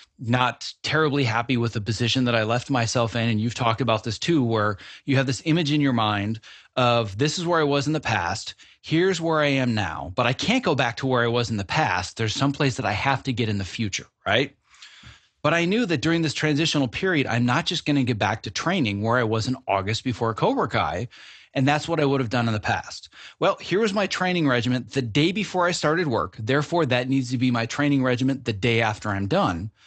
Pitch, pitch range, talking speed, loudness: 125 Hz, 115-150 Hz, 245 wpm, -23 LUFS